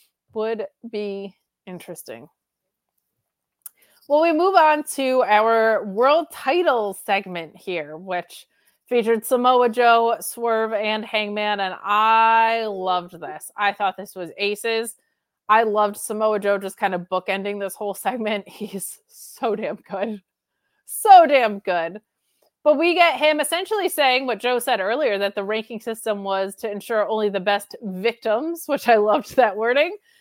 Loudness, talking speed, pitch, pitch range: -20 LUFS, 145 wpm, 220 Hz, 200-250 Hz